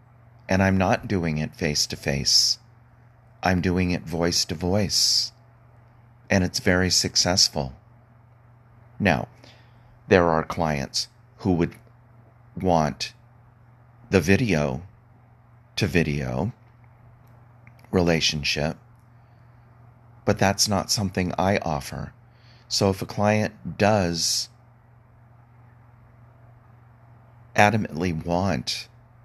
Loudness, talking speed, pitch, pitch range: -23 LUFS, 90 wpm, 115 Hz, 95-120 Hz